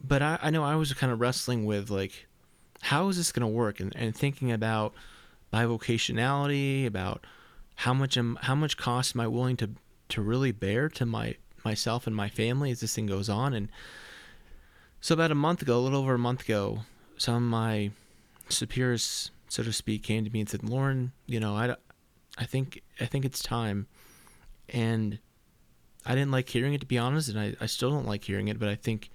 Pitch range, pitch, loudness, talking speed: 110-130 Hz, 120 Hz, -30 LUFS, 210 wpm